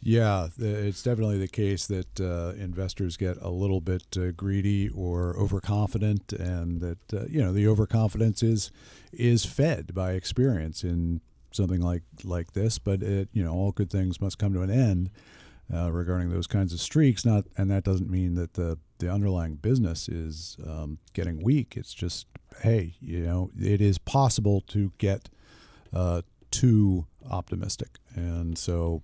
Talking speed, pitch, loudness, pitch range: 165 wpm, 95 Hz, -28 LUFS, 85-105 Hz